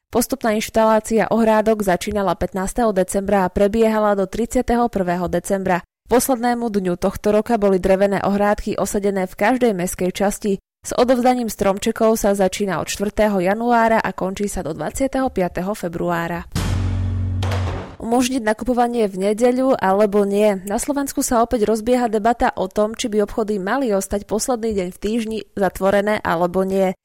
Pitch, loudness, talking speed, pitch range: 205 Hz, -19 LUFS, 140 wpm, 190-230 Hz